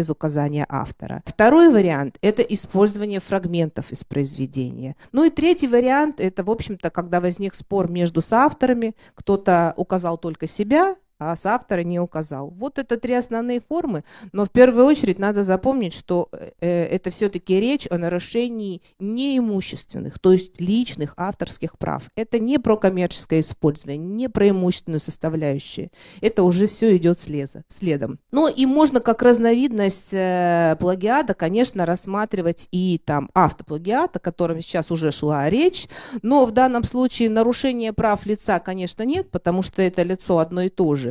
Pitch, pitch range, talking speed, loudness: 185 Hz, 170-230 Hz, 150 wpm, -20 LUFS